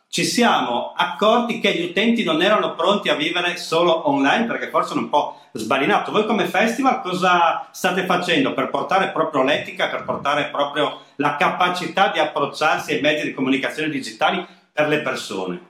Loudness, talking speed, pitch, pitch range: -19 LUFS, 170 wpm, 175 Hz, 150-190 Hz